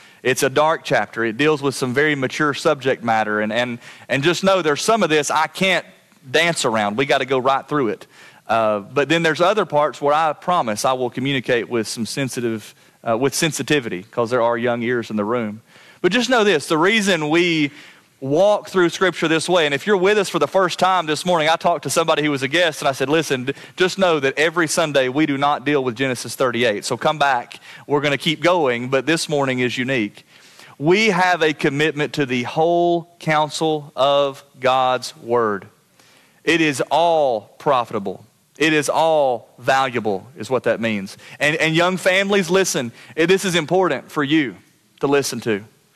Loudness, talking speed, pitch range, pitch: -19 LUFS, 200 wpm, 130-170 Hz, 150 Hz